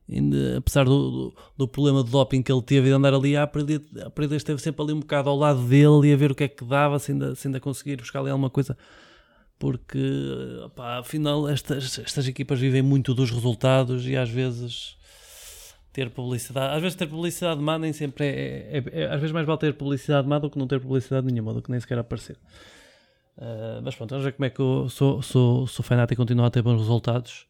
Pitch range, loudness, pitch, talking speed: 125-145 Hz, -24 LUFS, 135 Hz, 225 wpm